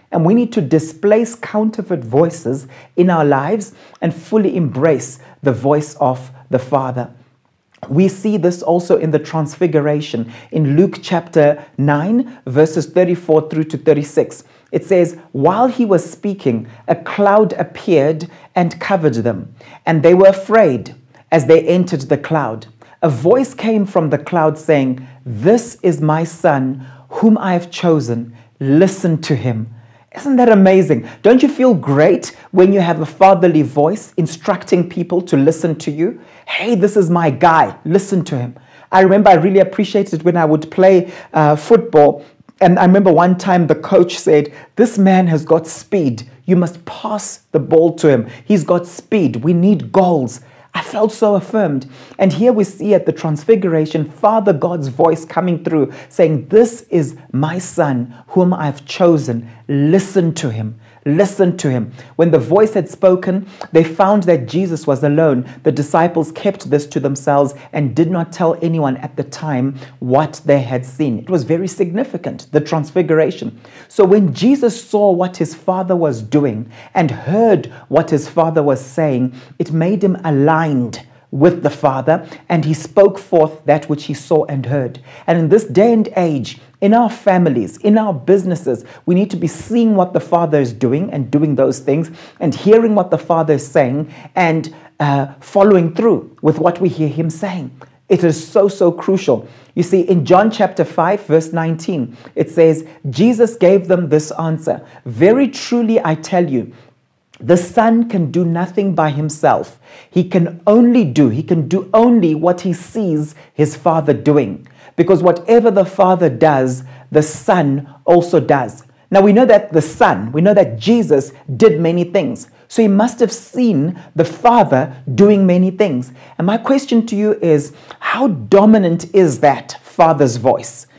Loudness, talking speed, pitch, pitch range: -14 LUFS, 170 wpm, 165 Hz, 145-190 Hz